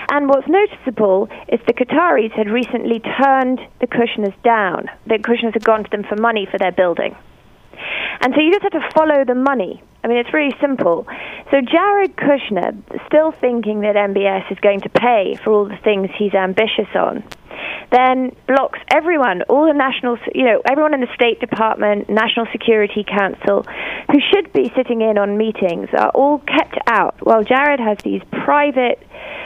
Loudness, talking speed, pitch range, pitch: -16 LUFS, 175 wpm, 215-285 Hz, 240 Hz